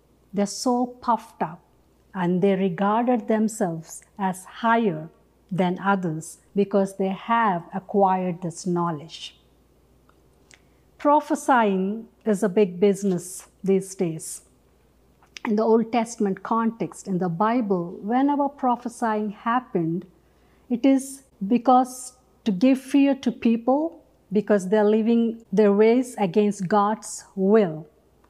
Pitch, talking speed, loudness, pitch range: 210 Hz, 110 wpm, -23 LUFS, 190-235 Hz